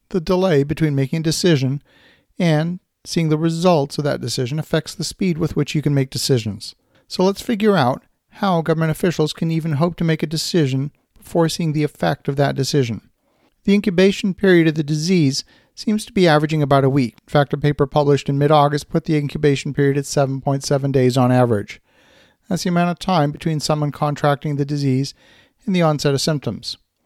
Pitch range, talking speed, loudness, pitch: 140-170 Hz, 195 wpm, -19 LUFS, 150 Hz